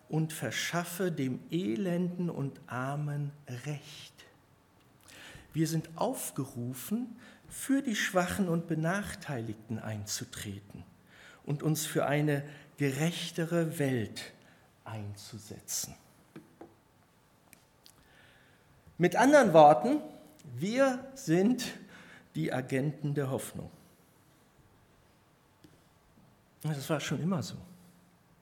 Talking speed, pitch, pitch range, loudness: 80 wpm, 150 Hz, 130-170 Hz, -31 LUFS